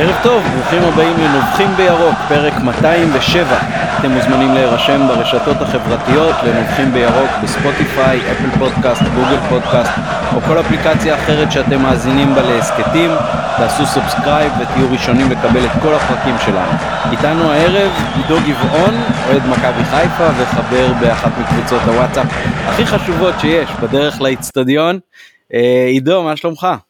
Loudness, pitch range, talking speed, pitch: -12 LUFS, 135-180 Hz, 125 wpm, 160 Hz